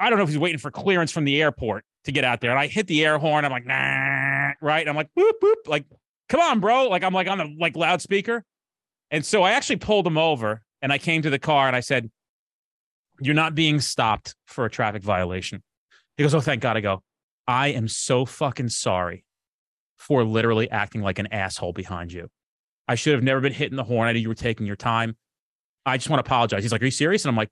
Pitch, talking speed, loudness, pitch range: 135 Hz, 245 wpm, -22 LUFS, 110-155 Hz